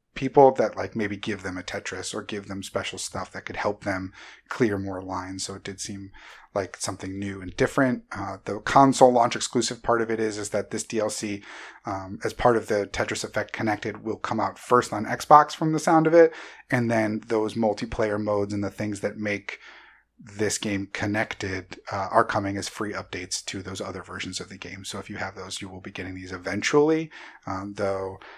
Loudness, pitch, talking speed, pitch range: -25 LUFS, 105 Hz, 210 wpm, 95-115 Hz